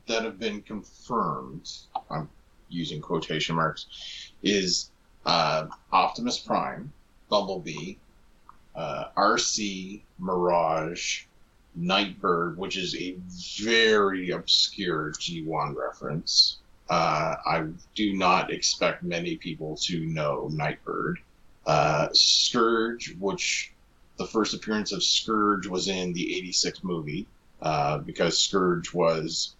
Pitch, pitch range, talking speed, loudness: 95 Hz, 90-110 Hz, 105 wpm, -26 LUFS